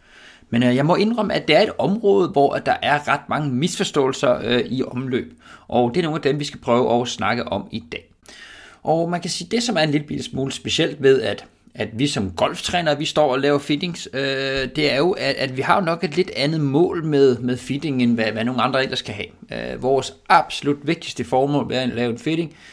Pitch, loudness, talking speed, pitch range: 140 Hz, -20 LUFS, 240 wpm, 130-160 Hz